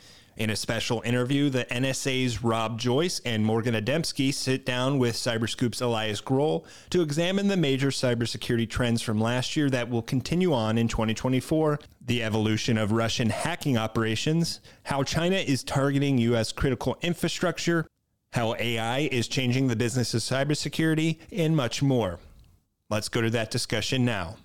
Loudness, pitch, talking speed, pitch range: -26 LUFS, 125 Hz, 150 wpm, 115-140 Hz